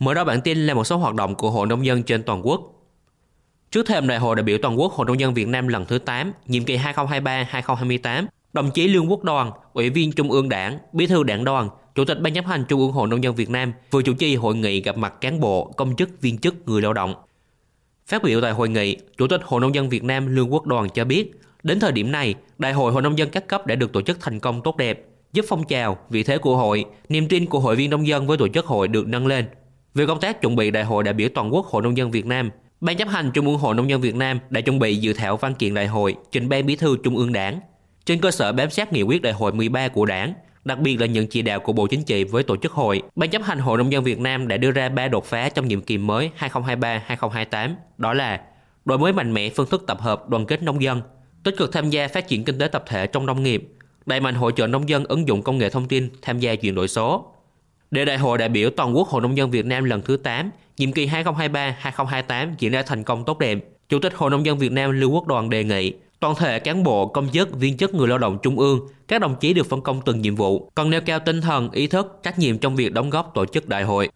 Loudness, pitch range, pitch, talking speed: -21 LUFS, 115-150 Hz, 130 Hz, 275 wpm